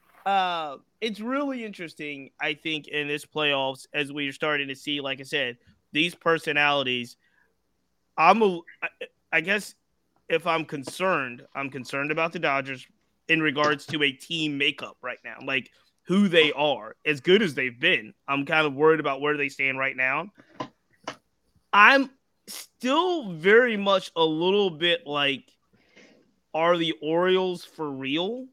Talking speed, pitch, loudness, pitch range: 150 wpm, 155 Hz, -24 LUFS, 140-180 Hz